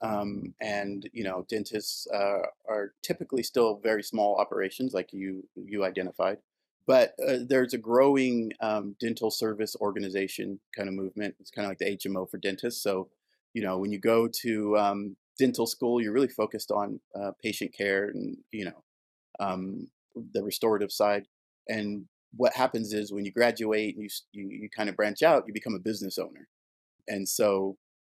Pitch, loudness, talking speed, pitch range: 105 Hz, -29 LUFS, 180 wpm, 95-110 Hz